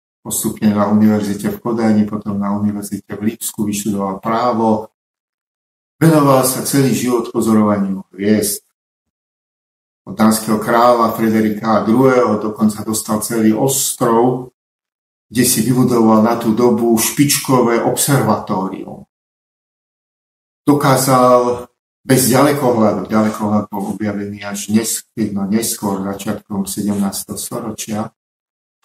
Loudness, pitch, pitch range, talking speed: -15 LUFS, 110 Hz, 105-120 Hz, 95 wpm